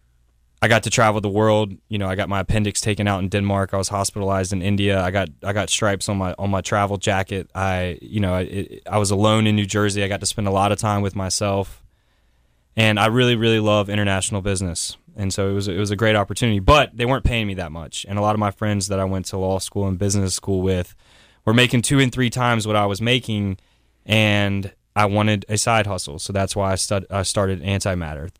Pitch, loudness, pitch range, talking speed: 100 Hz, -20 LUFS, 95-105 Hz, 245 wpm